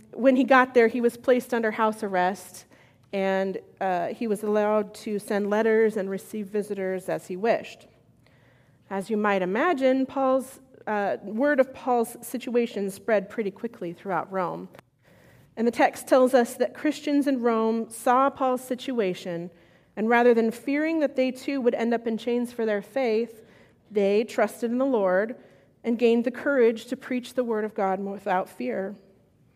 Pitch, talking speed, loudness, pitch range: 225 Hz, 170 wpm, -25 LUFS, 195-250 Hz